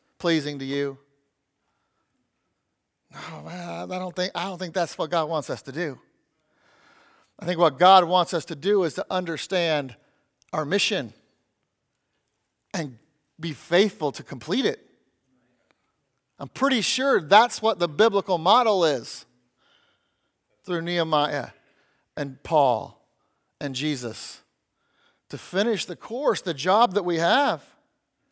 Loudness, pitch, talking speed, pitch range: -24 LUFS, 170 Hz, 130 wpm, 150-190 Hz